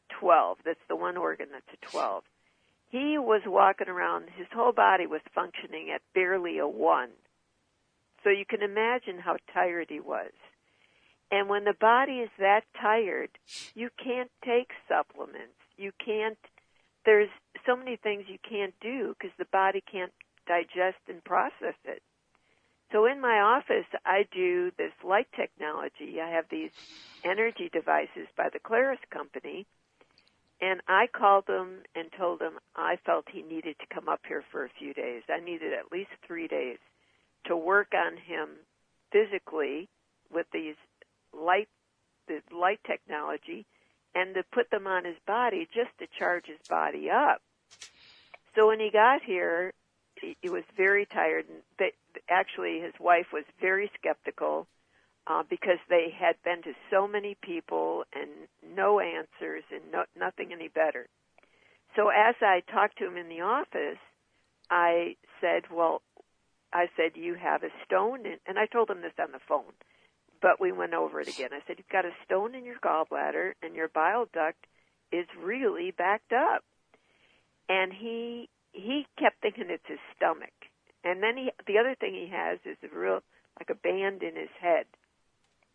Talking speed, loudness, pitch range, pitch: 165 wpm, -29 LUFS, 180-255 Hz, 205 Hz